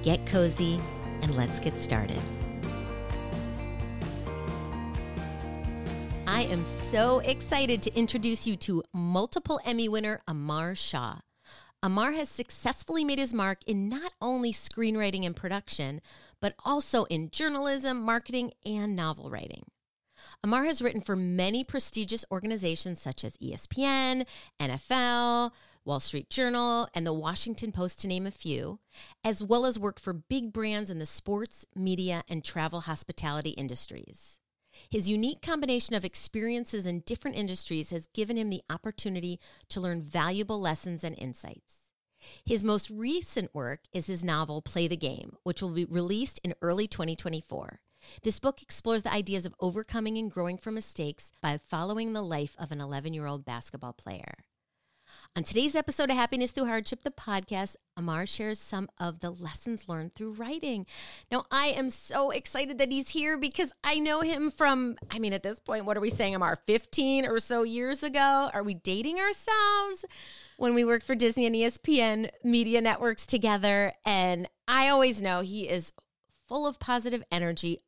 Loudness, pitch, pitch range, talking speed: -30 LUFS, 210 Hz, 170-245 Hz, 155 wpm